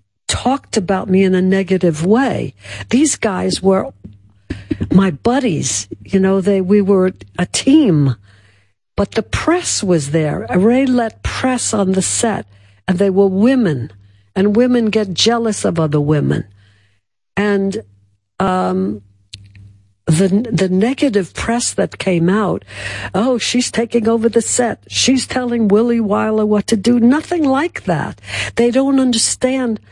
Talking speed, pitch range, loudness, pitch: 140 wpm, 145-235 Hz, -15 LUFS, 195 Hz